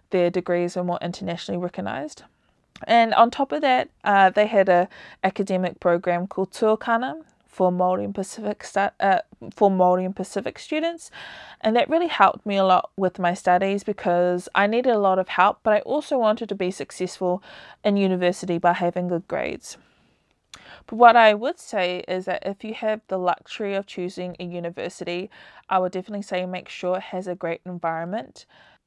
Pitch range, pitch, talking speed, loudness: 180-215 Hz, 190 Hz, 175 wpm, -22 LUFS